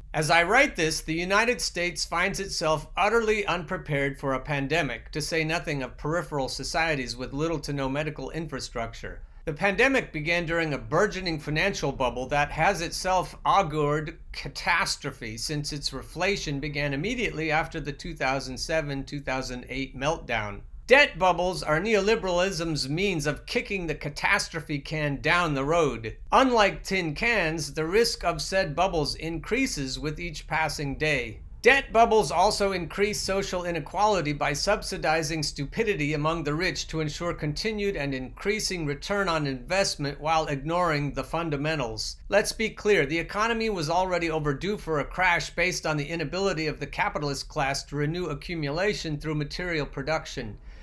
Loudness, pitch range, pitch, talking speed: -26 LUFS, 145-185 Hz, 160 Hz, 145 wpm